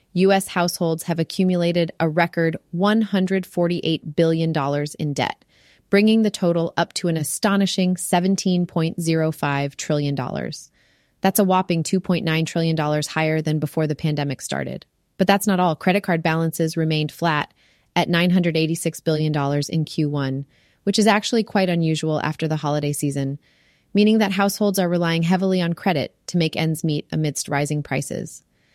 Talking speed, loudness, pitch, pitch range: 140 wpm, -21 LUFS, 165 Hz, 155-185 Hz